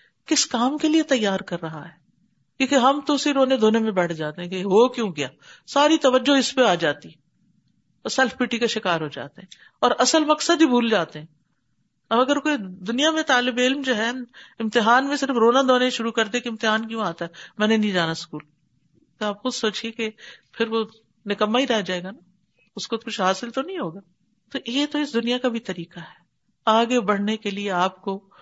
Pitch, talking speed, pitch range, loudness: 225 Hz, 220 wpm, 185-255 Hz, -22 LUFS